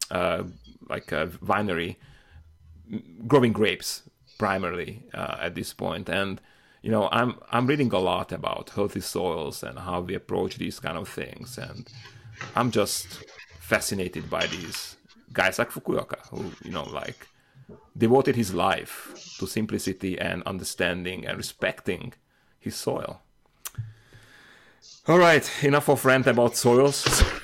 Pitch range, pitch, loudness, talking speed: 95-125 Hz, 110 Hz, -26 LUFS, 135 wpm